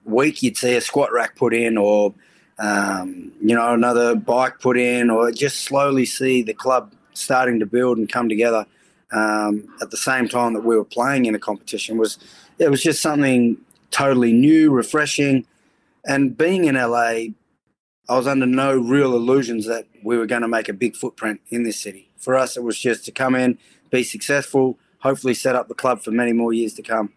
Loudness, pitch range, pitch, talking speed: -19 LUFS, 115-130 Hz, 120 Hz, 200 wpm